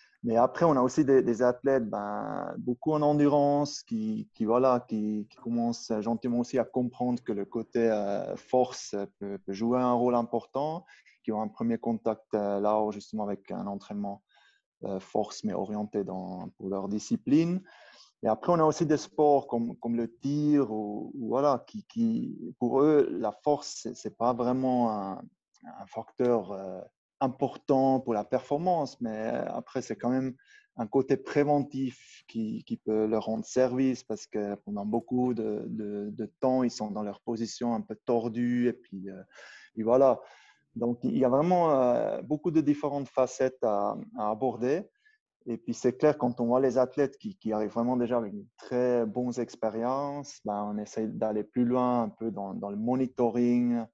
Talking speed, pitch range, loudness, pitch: 180 wpm, 110-135 Hz, -29 LUFS, 120 Hz